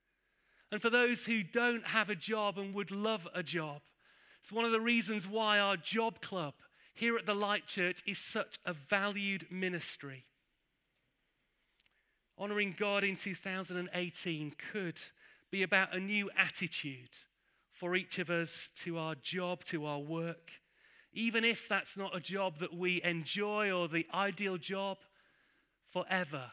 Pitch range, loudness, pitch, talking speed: 175-215 Hz, -35 LUFS, 195 Hz, 150 wpm